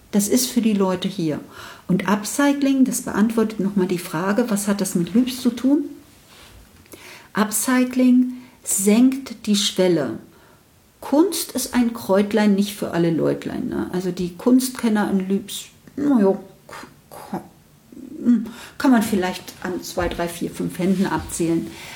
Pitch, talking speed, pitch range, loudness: 210 Hz, 135 wpm, 190-250 Hz, -20 LUFS